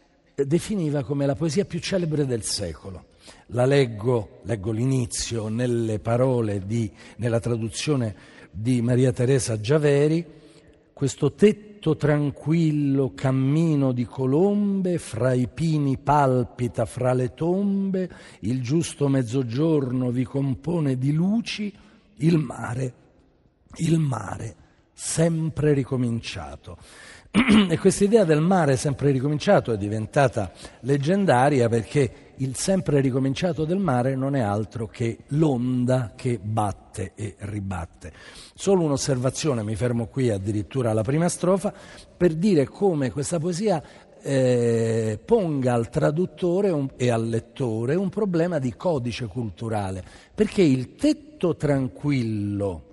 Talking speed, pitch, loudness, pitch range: 115 wpm, 135 Hz, -23 LUFS, 115-160 Hz